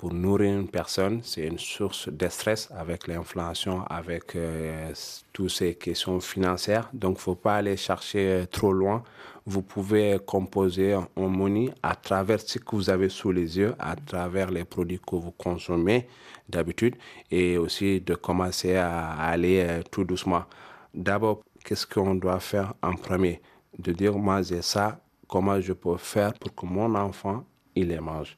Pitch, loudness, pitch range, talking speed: 95 Hz, -27 LUFS, 90-100 Hz, 165 wpm